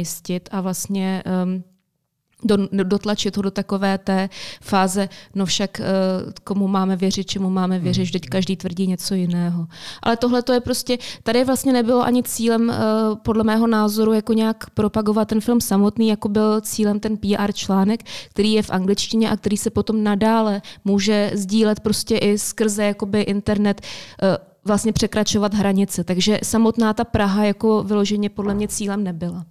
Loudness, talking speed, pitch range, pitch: -20 LUFS, 160 wpm, 190-220 Hz, 205 Hz